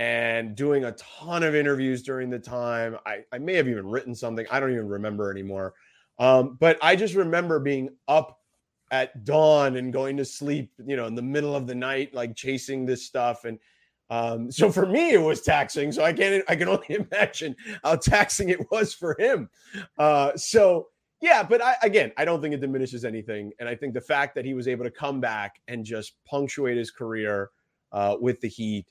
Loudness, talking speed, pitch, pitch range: -25 LUFS, 210 wpm, 130 Hz, 115-155 Hz